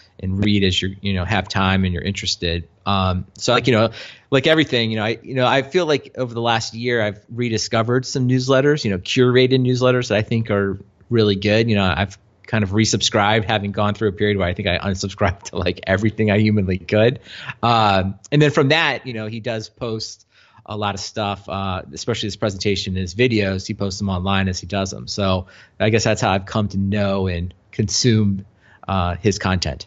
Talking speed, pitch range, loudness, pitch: 220 wpm, 95-115 Hz, -19 LUFS, 105 Hz